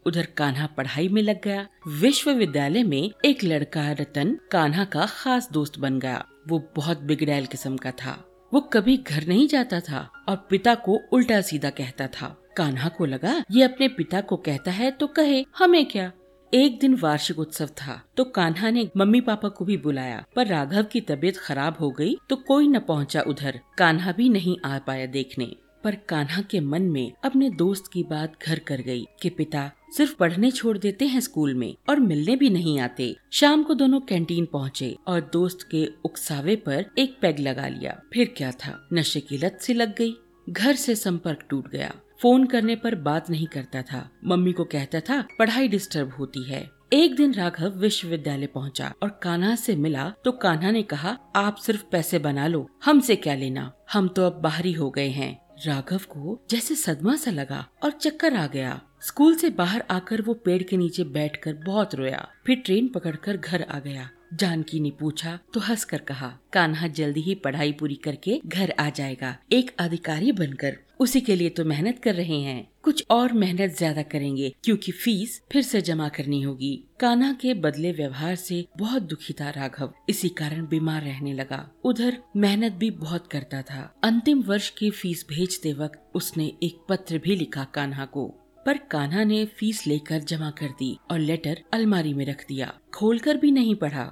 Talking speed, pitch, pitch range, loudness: 185 wpm, 175 Hz, 150-225 Hz, -24 LUFS